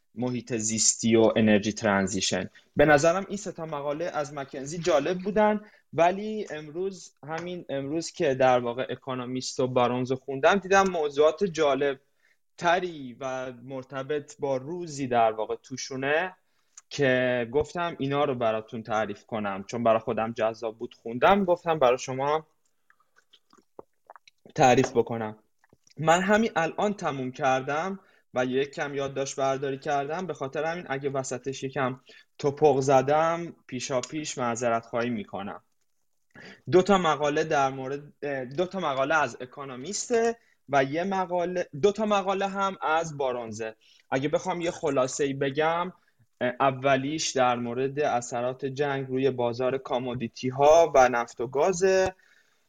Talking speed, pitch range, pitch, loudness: 135 wpm, 125-170 Hz, 140 Hz, -26 LUFS